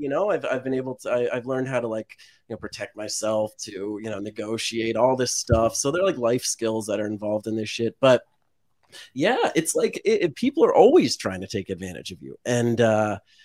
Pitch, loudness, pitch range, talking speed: 115 Hz, -23 LUFS, 110-130 Hz, 230 wpm